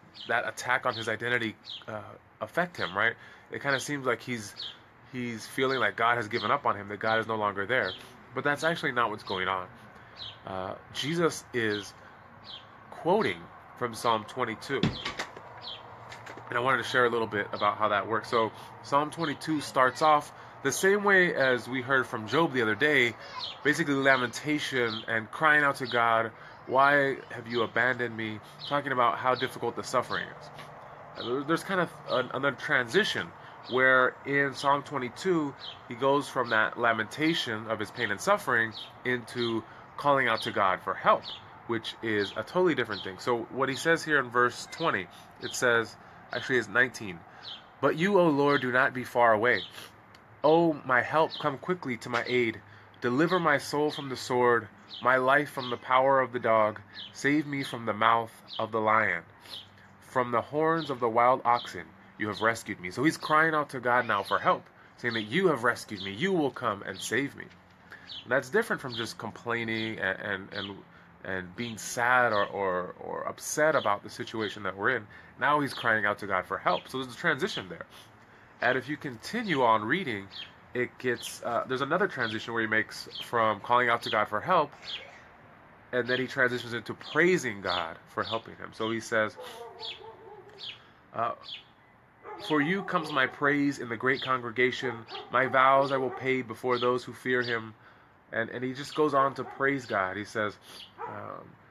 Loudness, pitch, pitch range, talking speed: -28 LUFS, 125 Hz, 110-135 Hz, 180 wpm